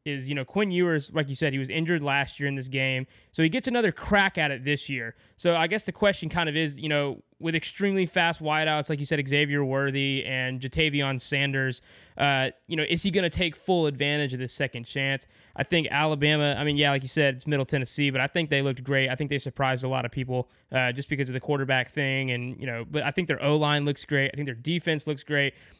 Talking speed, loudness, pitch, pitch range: 260 wpm, -26 LUFS, 145 Hz, 135-155 Hz